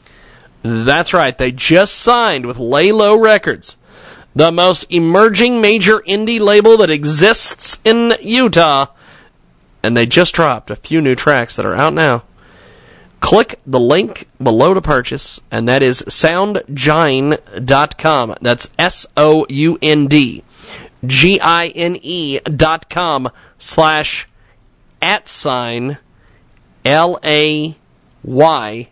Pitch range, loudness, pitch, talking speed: 130-180 Hz, -12 LUFS, 155 Hz, 100 wpm